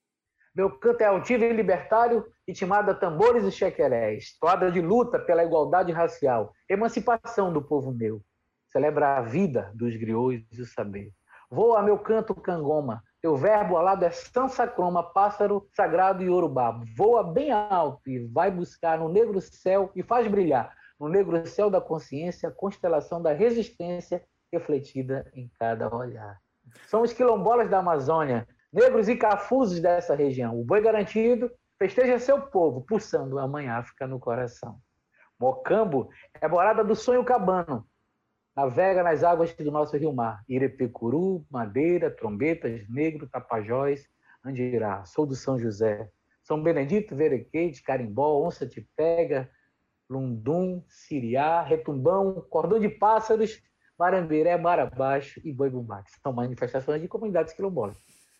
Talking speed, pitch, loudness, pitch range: 140 wpm, 165 Hz, -25 LUFS, 130-205 Hz